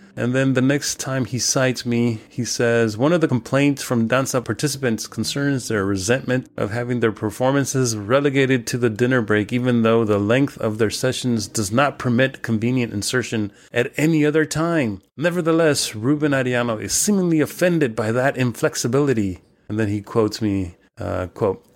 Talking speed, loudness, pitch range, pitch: 170 wpm, -20 LUFS, 110-135 Hz, 125 Hz